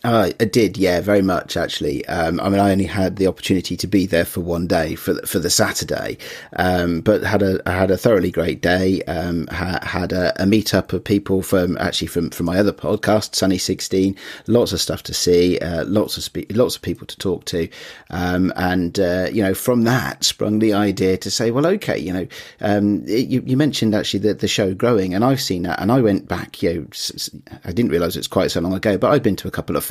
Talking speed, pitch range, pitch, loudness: 245 wpm, 90-105 Hz, 95 Hz, -19 LUFS